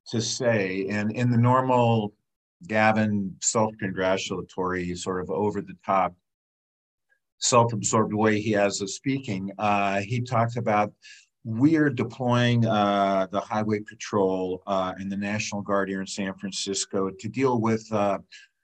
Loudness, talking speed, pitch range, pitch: -25 LUFS, 130 wpm, 95-115 Hz, 105 Hz